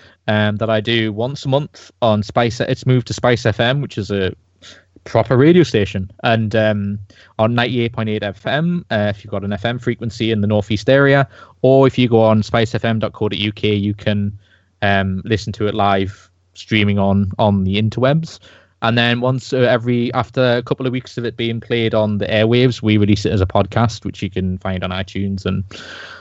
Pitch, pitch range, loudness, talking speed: 110 Hz, 100-120 Hz, -17 LUFS, 195 wpm